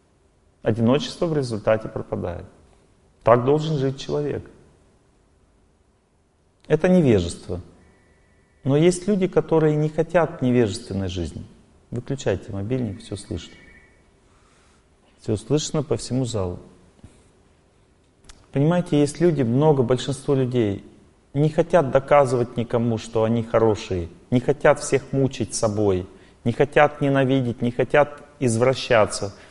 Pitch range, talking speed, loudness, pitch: 95-140 Hz, 105 wpm, -22 LUFS, 115 Hz